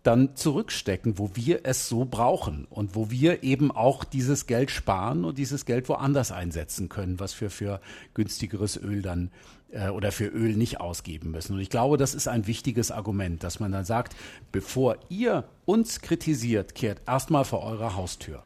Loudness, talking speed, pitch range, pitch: -28 LUFS, 180 wpm, 100-135 Hz, 115 Hz